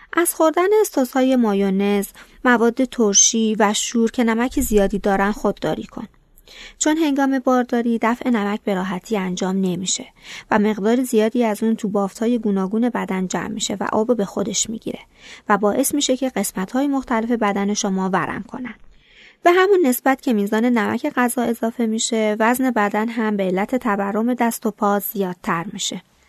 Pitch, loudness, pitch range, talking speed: 220 Hz, -19 LUFS, 205-250 Hz, 160 wpm